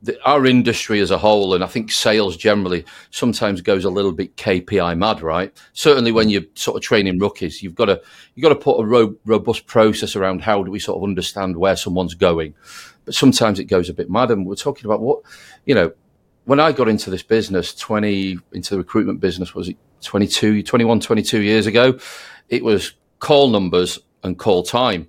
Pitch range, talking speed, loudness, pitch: 95-110 Hz, 200 wpm, -17 LUFS, 100 Hz